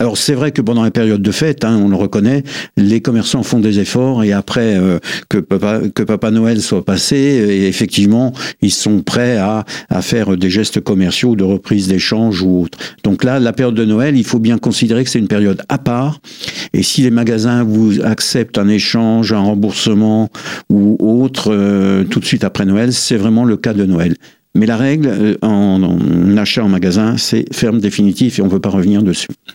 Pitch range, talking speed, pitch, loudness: 100-120 Hz, 210 wpm, 110 Hz, -13 LUFS